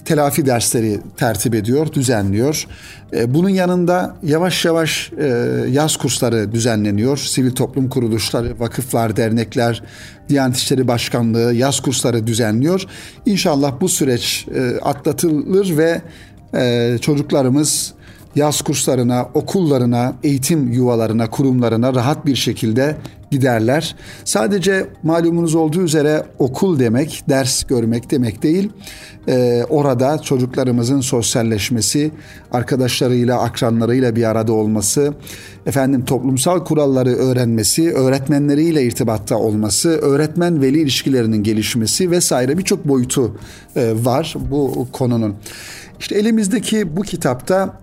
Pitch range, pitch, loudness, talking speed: 115-155 Hz, 130 Hz, -16 LUFS, 100 wpm